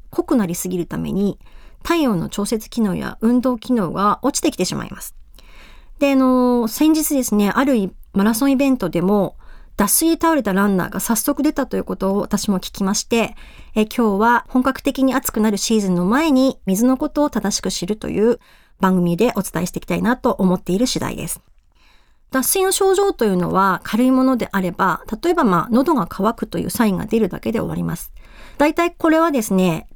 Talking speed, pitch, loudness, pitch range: 380 characters per minute, 225 Hz, -18 LUFS, 195-265 Hz